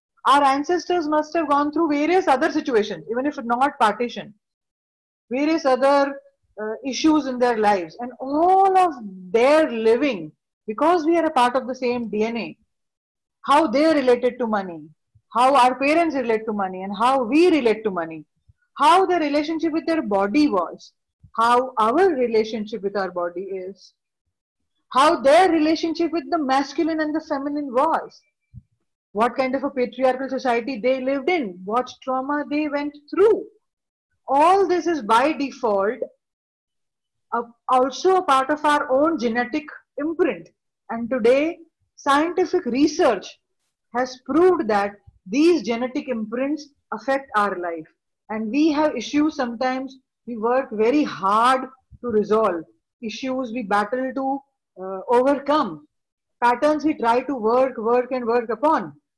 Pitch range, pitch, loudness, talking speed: 225-300 Hz, 260 Hz, -21 LUFS, 145 wpm